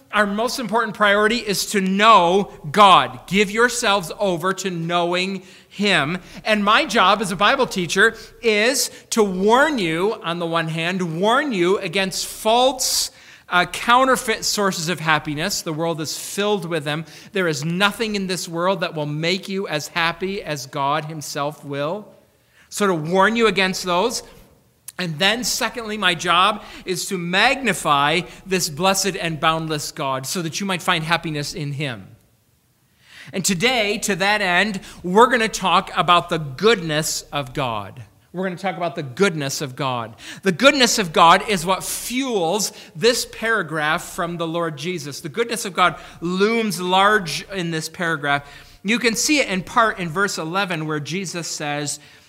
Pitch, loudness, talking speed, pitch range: 185 Hz, -19 LUFS, 165 wpm, 160-205 Hz